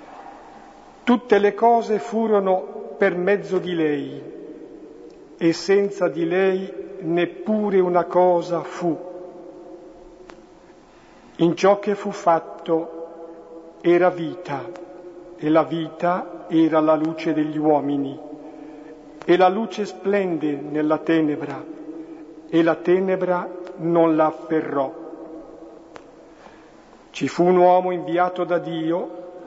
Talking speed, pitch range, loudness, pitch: 100 wpm, 160-180 Hz, -21 LUFS, 175 Hz